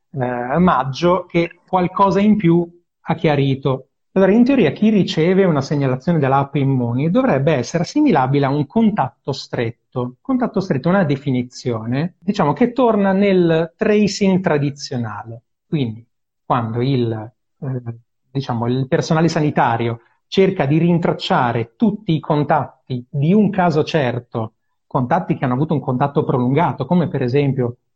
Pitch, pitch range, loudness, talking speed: 150 Hz, 125-175 Hz, -18 LUFS, 135 wpm